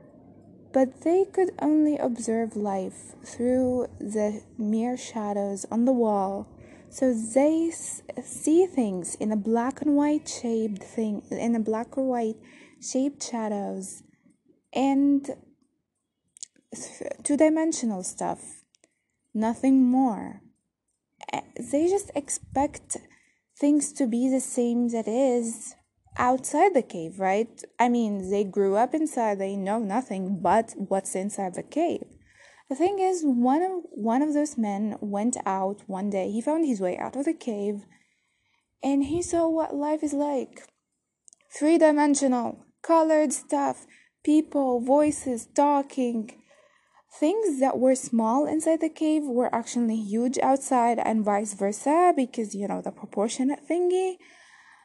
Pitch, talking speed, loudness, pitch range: 255 Hz, 130 wpm, -26 LUFS, 220-295 Hz